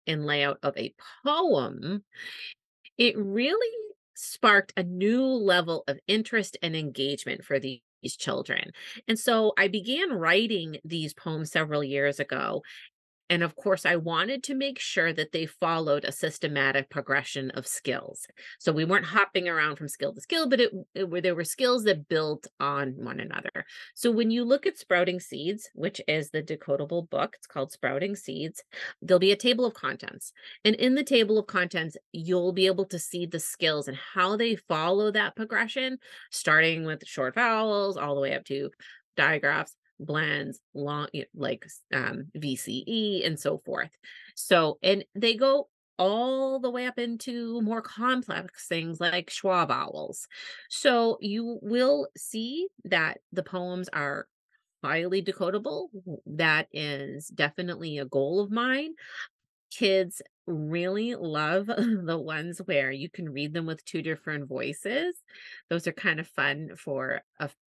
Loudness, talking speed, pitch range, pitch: -28 LUFS, 160 wpm, 155-220 Hz, 180 Hz